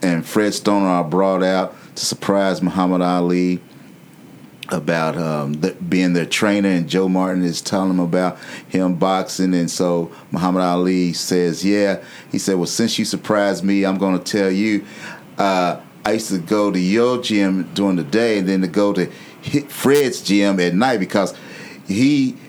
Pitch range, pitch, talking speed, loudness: 90-100 Hz, 95 Hz, 175 wpm, -18 LUFS